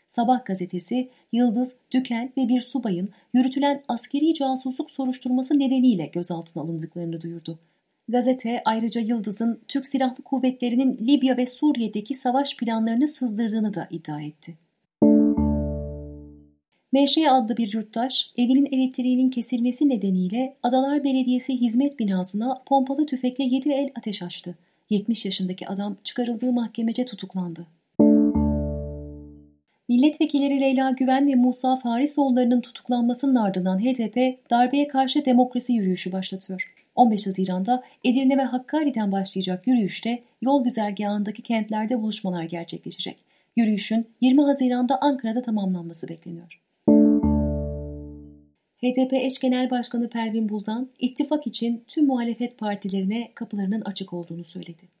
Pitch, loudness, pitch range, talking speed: 235 Hz, -23 LUFS, 185-255 Hz, 110 wpm